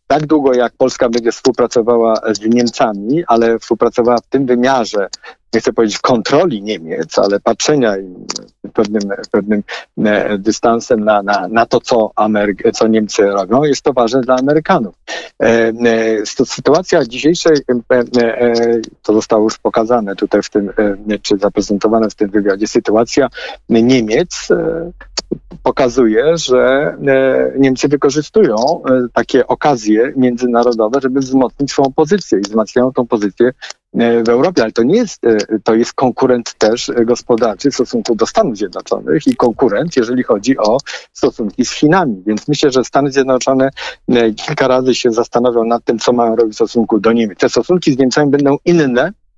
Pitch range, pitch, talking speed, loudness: 110-135 Hz, 120 Hz, 140 wpm, -13 LUFS